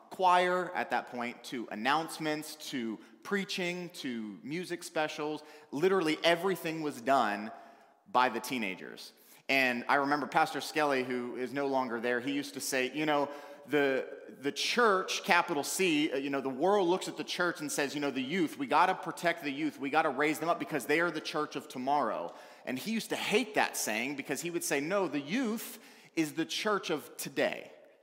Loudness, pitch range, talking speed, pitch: -32 LUFS, 140-180 Hz, 195 wpm, 155 Hz